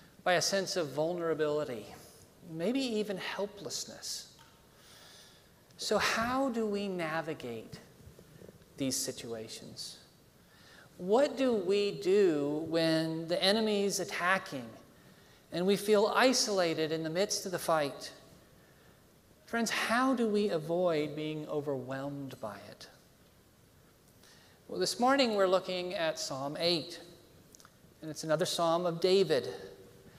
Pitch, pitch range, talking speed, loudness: 175 Hz, 155-205 Hz, 110 wpm, -32 LUFS